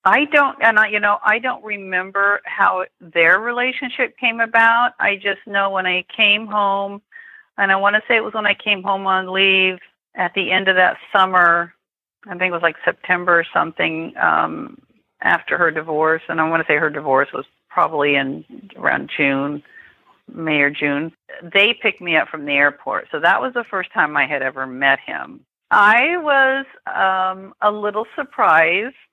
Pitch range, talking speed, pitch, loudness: 165-215 Hz, 185 wpm, 190 Hz, -17 LUFS